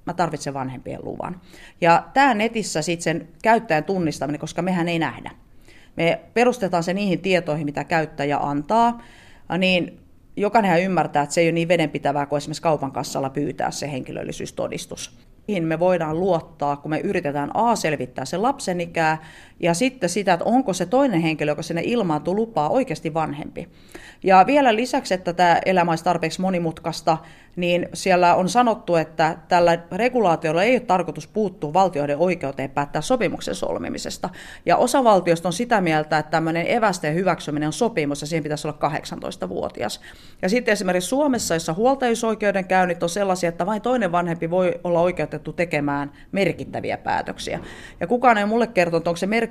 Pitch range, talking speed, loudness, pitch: 155-195 Hz, 160 wpm, -21 LUFS, 170 Hz